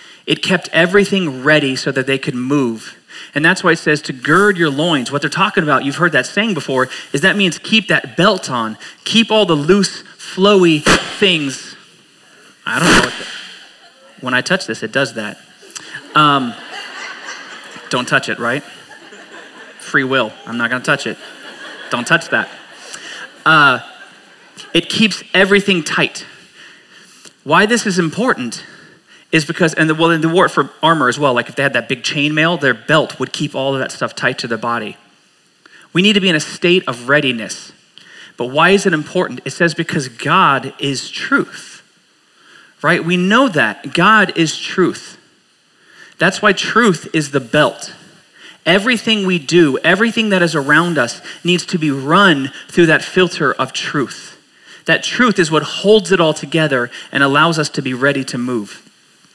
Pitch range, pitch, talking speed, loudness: 140-190 Hz, 160 Hz, 175 wpm, -14 LUFS